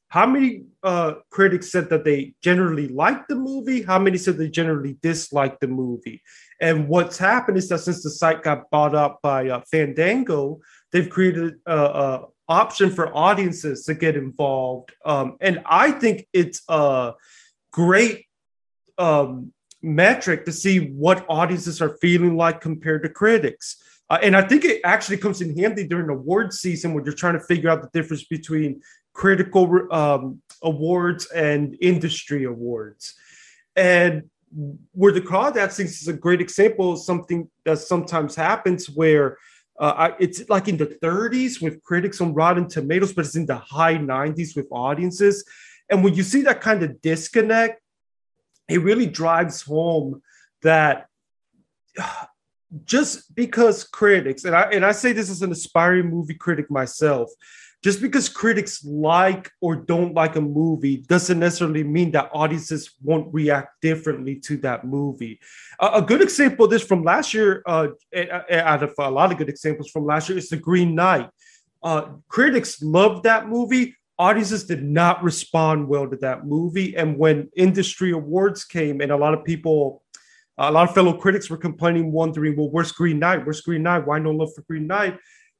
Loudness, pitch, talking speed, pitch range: -20 LUFS, 170 Hz, 170 wpm, 155-195 Hz